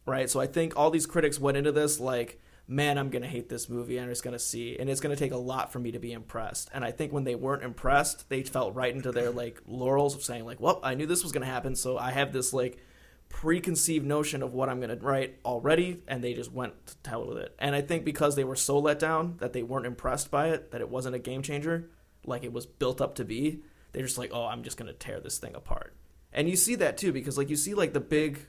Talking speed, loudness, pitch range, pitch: 270 wpm, -30 LUFS, 125-150 Hz, 135 Hz